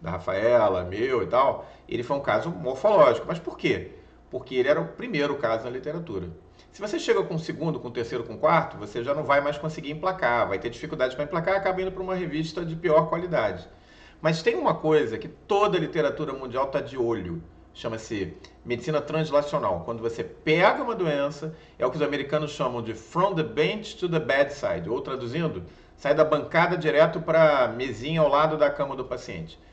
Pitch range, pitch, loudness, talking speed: 130-165 Hz, 150 Hz, -25 LUFS, 205 wpm